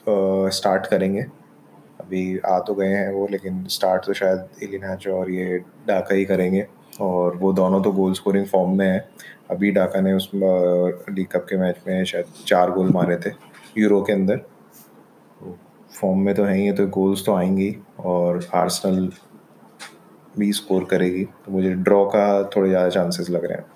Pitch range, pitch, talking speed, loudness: 90-100 Hz, 95 Hz, 175 wpm, -21 LUFS